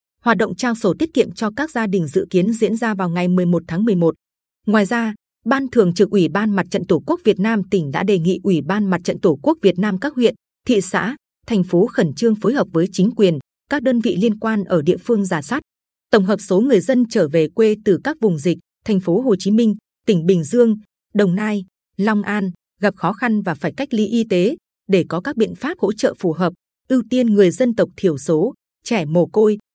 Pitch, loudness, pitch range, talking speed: 205 Hz, -18 LUFS, 185-230 Hz, 240 wpm